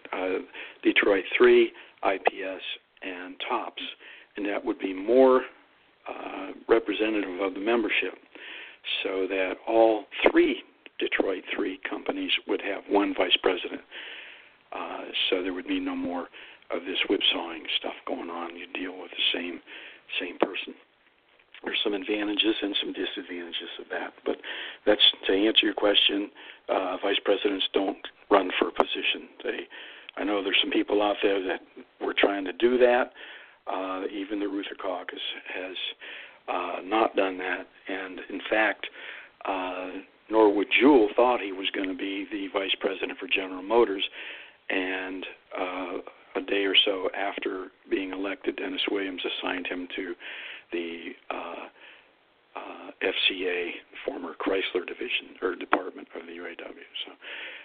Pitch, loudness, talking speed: 110 Hz, -27 LUFS, 145 wpm